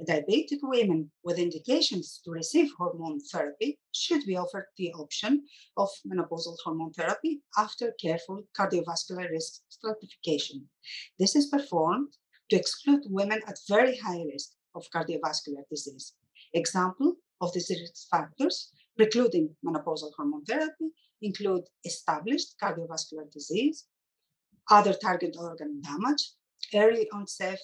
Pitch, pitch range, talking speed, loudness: 185 Hz, 165-235 Hz, 115 wpm, -29 LUFS